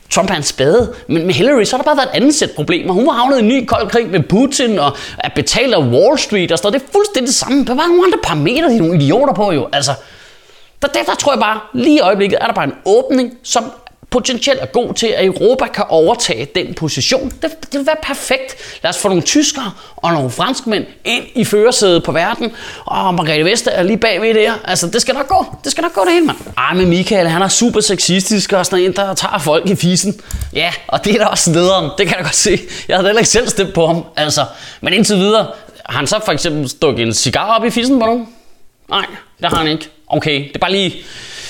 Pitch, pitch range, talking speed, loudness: 215 Hz, 180-255 Hz, 255 wpm, -13 LUFS